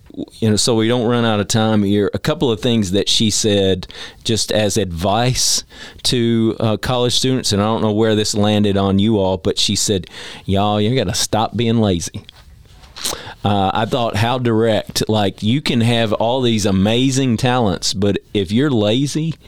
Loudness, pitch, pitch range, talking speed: -16 LUFS, 110 Hz, 100-120 Hz, 185 wpm